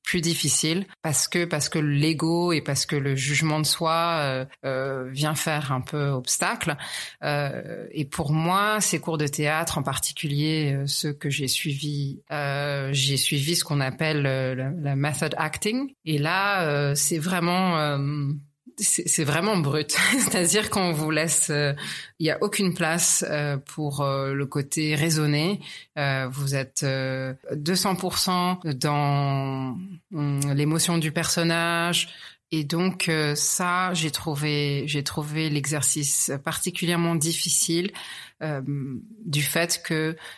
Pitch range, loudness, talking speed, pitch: 145-170 Hz, -24 LUFS, 145 wpm, 155 Hz